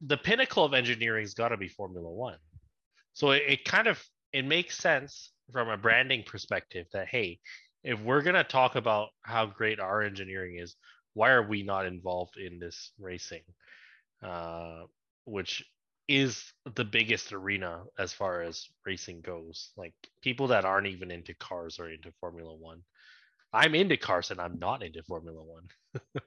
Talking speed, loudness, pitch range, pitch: 170 wpm, -29 LUFS, 85-125 Hz, 100 Hz